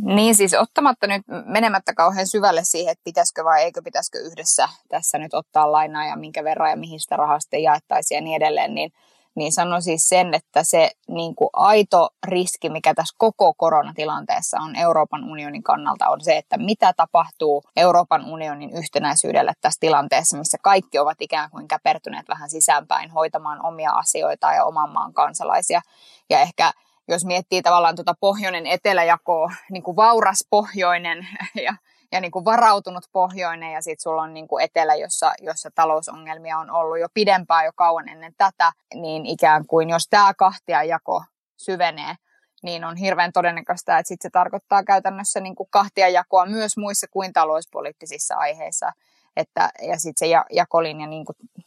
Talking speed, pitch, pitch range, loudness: 165 wpm, 175 Hz, 160-195 Hz, -20 LUFS